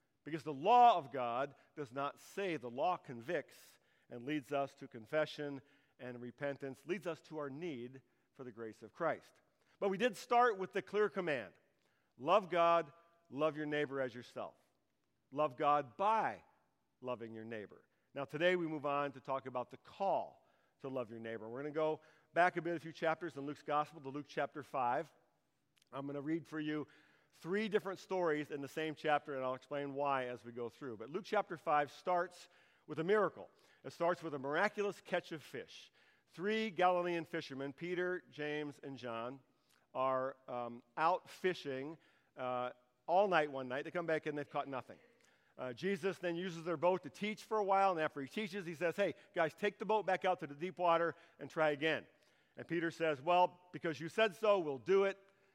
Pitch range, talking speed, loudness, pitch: 135-175 Hz, 195 wpm, -38 LUFS, 155 Hz